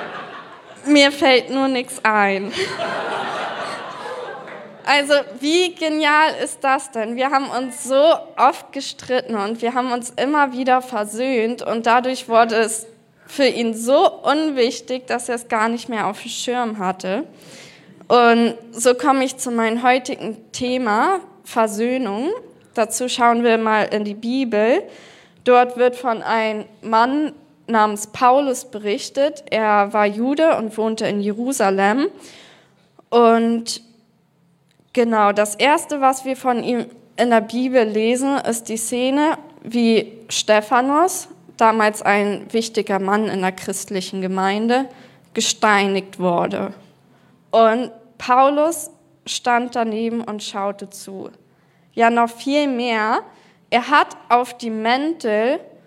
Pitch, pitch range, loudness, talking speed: 235 Hz, 215-265 Hz, -18 LUFS, 125 wpm